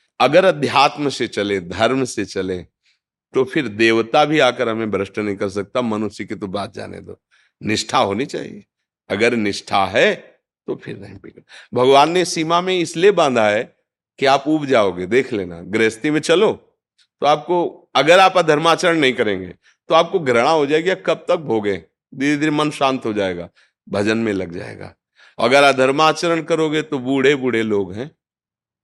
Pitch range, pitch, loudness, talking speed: 105-155 Hz, 130 Hz, -17 LUFS, 170 wpm